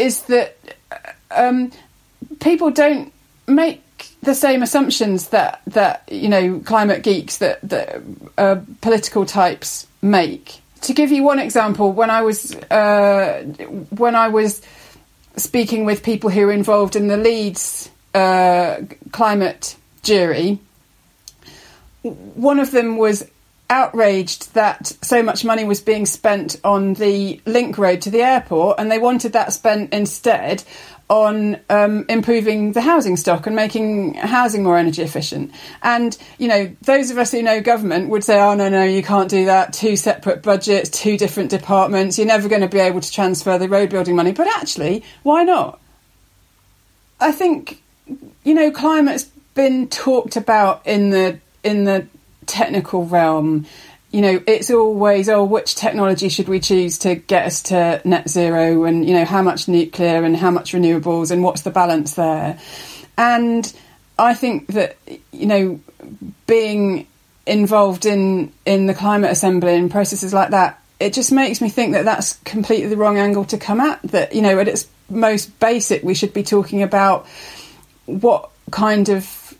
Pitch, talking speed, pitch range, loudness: 205 Hz, 160 wpm, 190-230 Hz, -16 LUFS